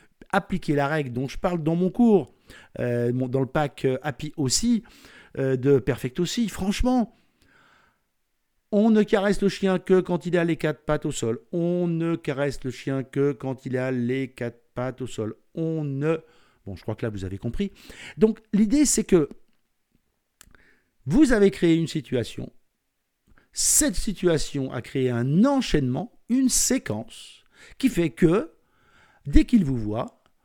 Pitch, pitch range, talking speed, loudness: 160 Hz, 130-200 Hz, 165 wpm, -24 LUFS